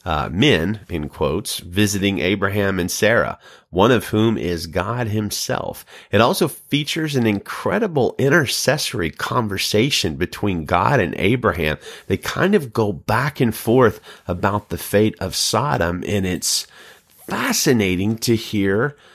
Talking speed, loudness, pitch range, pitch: 130 wpm, -19 LUFS, 95-115 Hz, 105 Hz